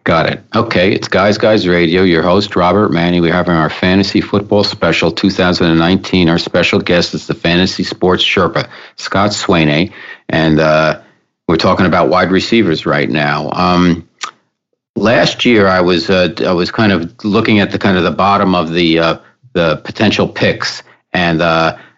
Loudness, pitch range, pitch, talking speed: -12 LUFS, 80-100 Hz, 90 Hz, 170 wpm